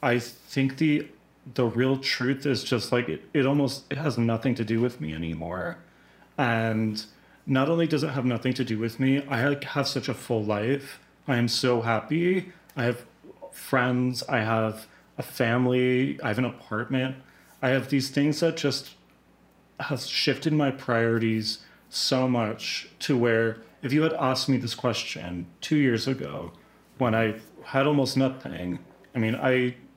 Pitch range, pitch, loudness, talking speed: 115-140 Hz, 125 Hz, -26 LUFS, 170 wpm